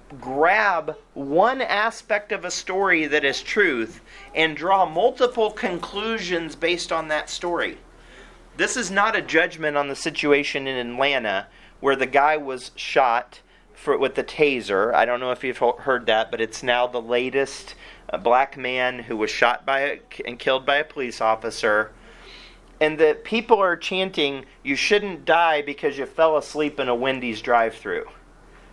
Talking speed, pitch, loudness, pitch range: 165 wpm, 150 Hz, -22 LUFS, 130-180 Hz